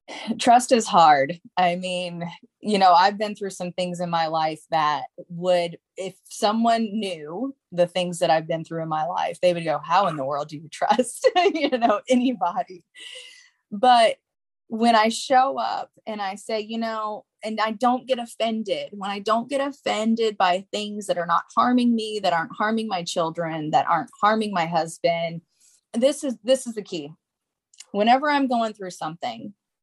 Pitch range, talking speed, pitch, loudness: 175-240 Hz, 180 wpm, 210 Hz, -23 LUFS